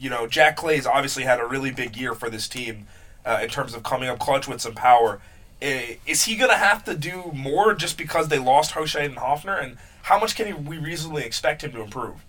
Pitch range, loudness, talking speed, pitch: 120-155 Hz, -22 LUFS, 235 wpm, 140 Hz